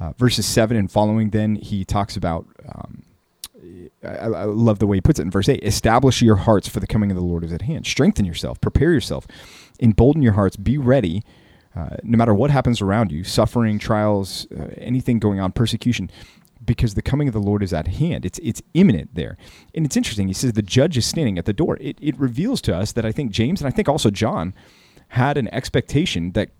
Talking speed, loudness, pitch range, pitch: 225 wpm, -19 LUFS, 100-125 Hz, 110 Hz